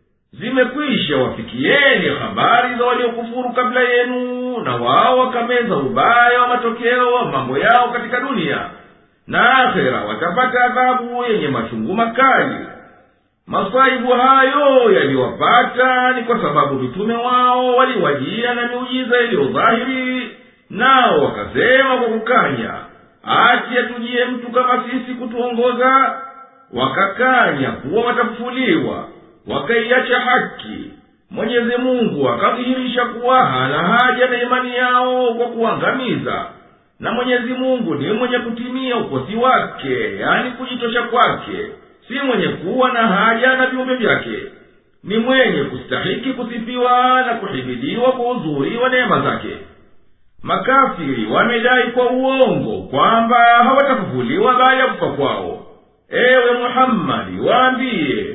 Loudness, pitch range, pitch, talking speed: -15 LUFS, 235-255 Hz, 245 Hz, 105 wpm